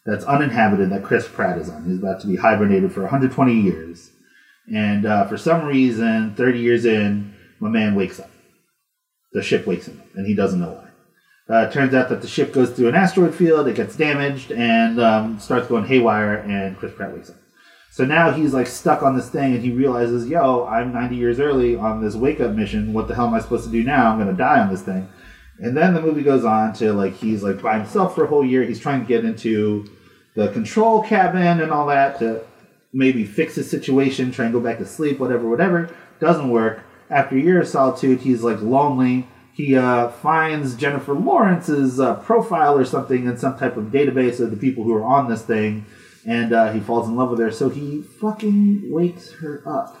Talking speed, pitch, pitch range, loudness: 220 wpm, 125 Hz, 110-145 Hz, -19 LUFS